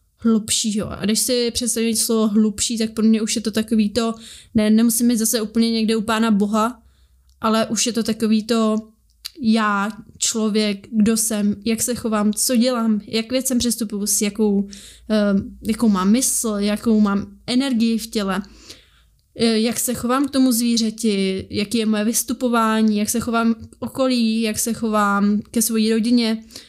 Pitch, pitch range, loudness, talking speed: 225 Hz, 215-235 Hz, -19 LUFS, 165 wpm